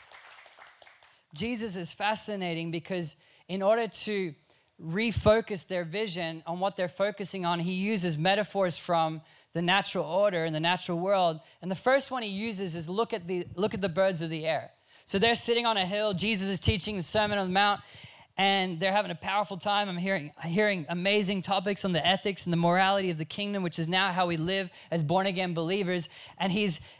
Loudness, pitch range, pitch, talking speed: -28 LUFS, 170-205 Hz, 190 Hz, 200 wpm